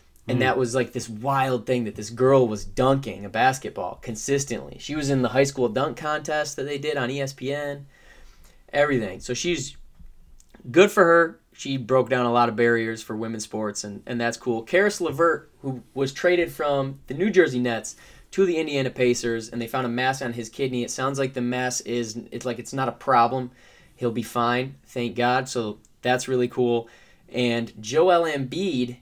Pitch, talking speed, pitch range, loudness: 125 Hz, 195 wpm, 120-140 Hz, -24 LUFS